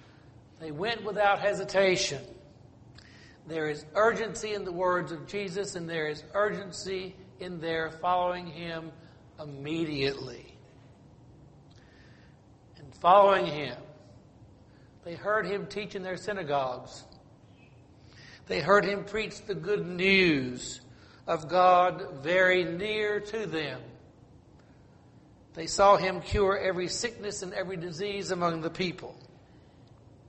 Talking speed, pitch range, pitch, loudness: 110 wpm, 140-195 Hz, 175 Hz, -28 LUFS